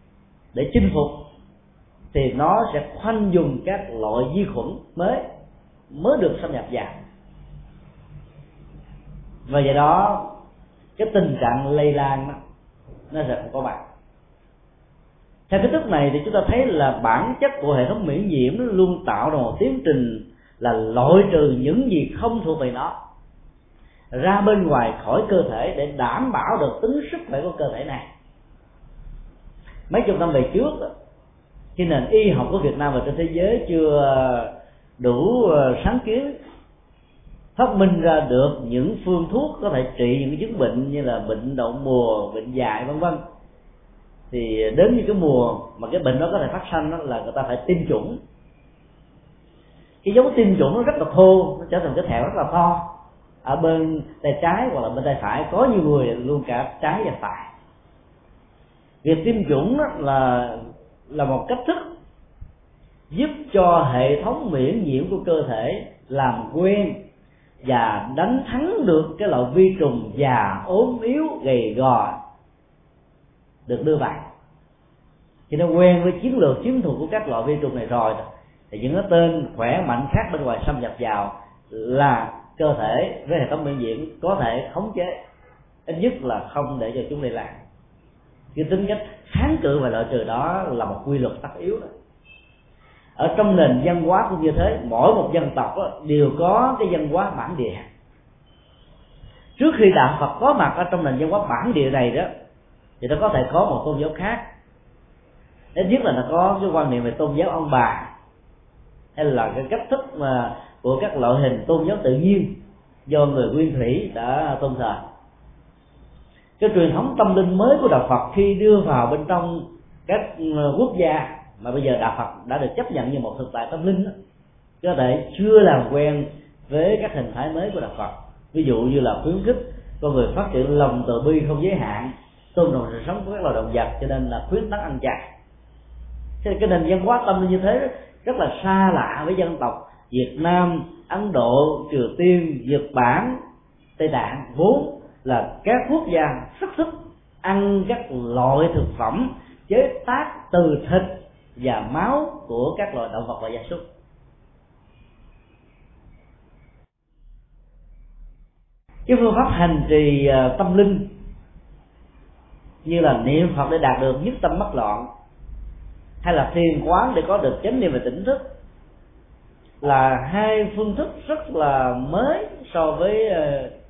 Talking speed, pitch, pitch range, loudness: 180 wpm, 155 Hz, 130-195 Hz, -20 LUFS